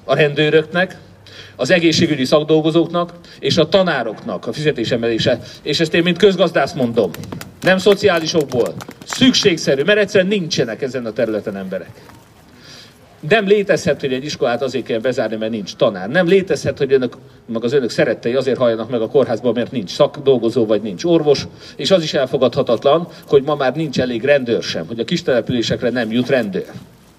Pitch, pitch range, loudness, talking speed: 150 Hz, 125-175 Hz, -16 LUFS, 165 wpm